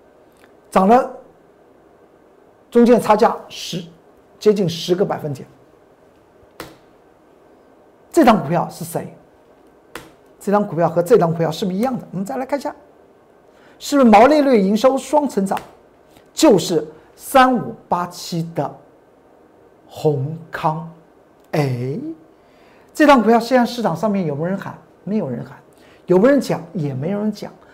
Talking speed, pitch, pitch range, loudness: 200 characters per minute, 195 Hz, 165-240 Hz, -17 LUFS